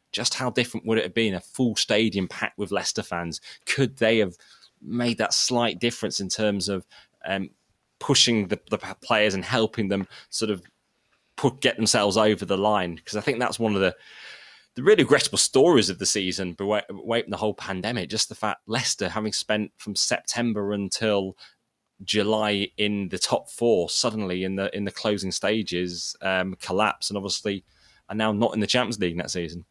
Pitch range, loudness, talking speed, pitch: 95-110 Hz, -24 LUFS, 190 wpm, 105 Hz